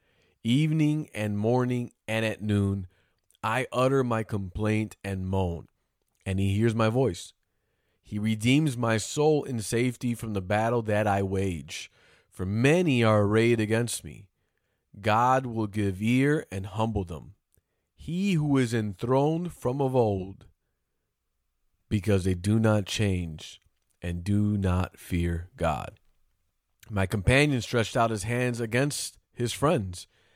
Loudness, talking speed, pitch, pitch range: -27 LUFS, 135 wpm, 110 Hz, 95-120 Hz